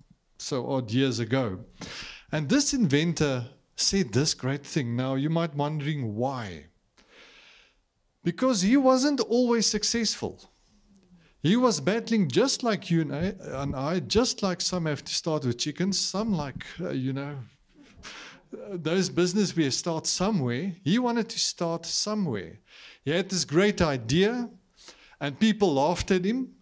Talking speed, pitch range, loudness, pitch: 145 wpm, 140-210 Hz, -26 LUFS, 175 Hz